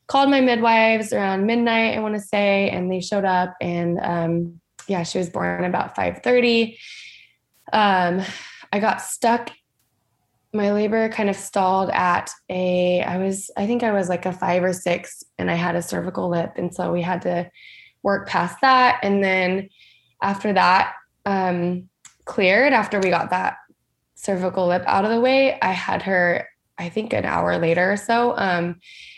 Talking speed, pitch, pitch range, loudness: 175 wpm, 190 Hz, 175-210 Hz, -21 LUFS